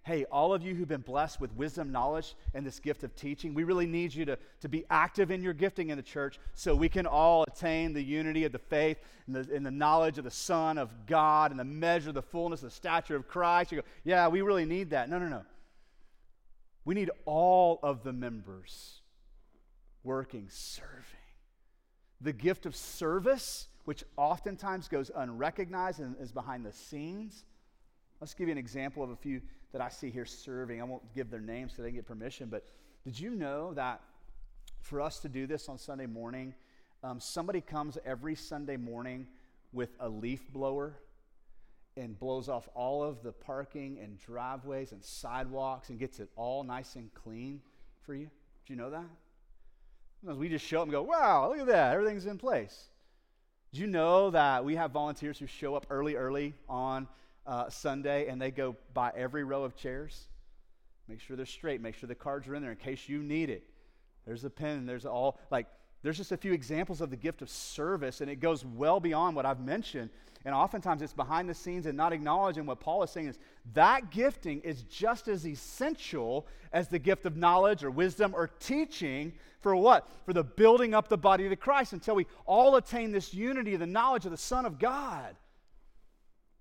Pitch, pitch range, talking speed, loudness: 150 Hz, 130-175 Hz, 200 wpm, -32 LUFS